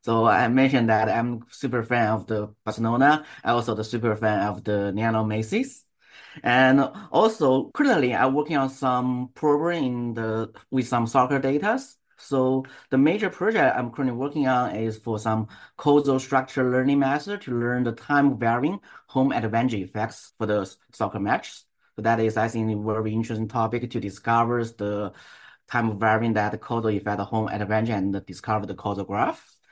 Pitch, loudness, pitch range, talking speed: 115 Hz, -24 LUFS, 110-130 Hz, 170 wpm